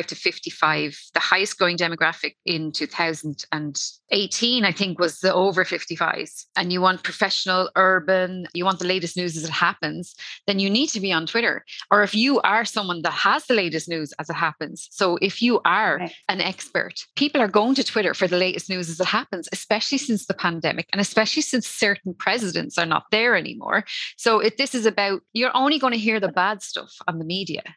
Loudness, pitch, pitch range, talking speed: -22 LUFS, 190 Hz, 175-220 Hz, 205 wpm